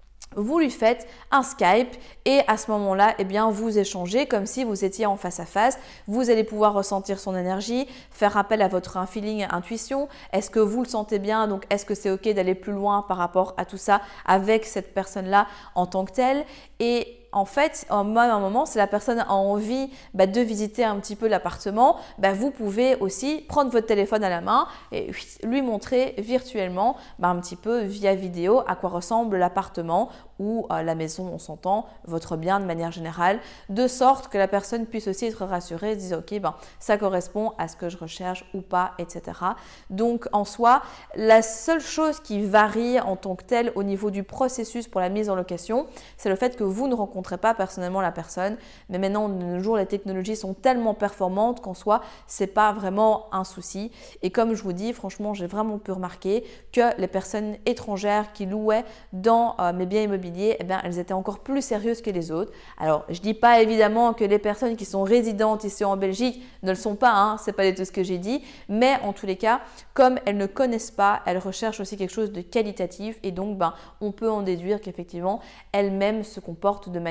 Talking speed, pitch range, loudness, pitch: 210 wpm, 190-230 Hz, -24 LUFS, 205 Hz